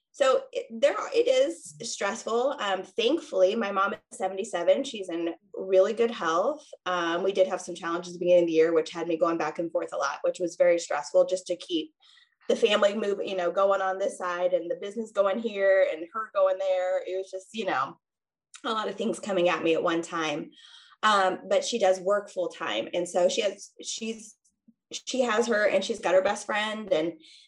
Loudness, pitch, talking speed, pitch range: -27 LUFS, 195 Hz, 220 wpm, 175-230 Hz